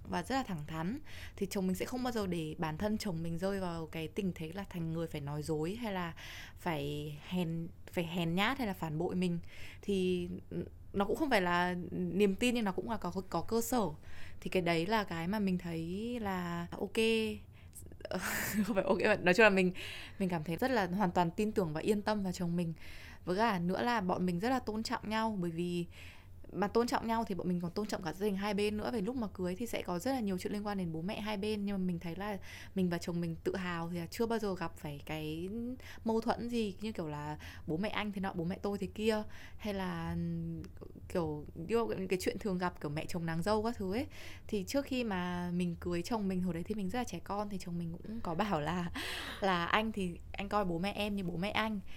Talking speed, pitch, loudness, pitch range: 255 wpm, 190 Hz, -36 LUFS, 170-215 Hz